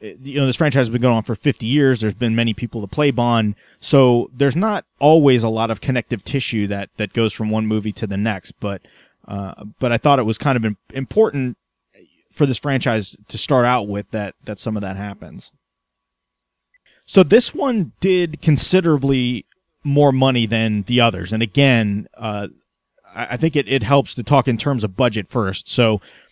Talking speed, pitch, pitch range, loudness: 195 wpm, 120 Hz, 110-140 Hz, -18 LUFS